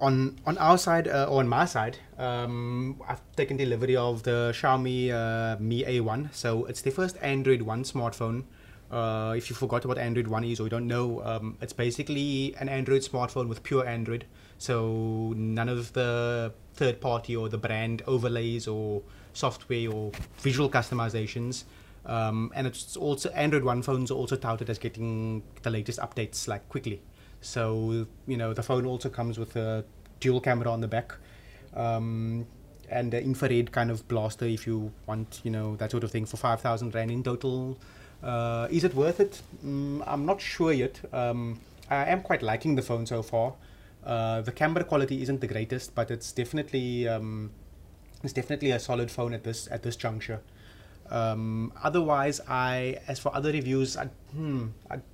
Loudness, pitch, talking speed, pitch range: -30 LUFS, 120 Hz, 180 wpm, 110-130 Hz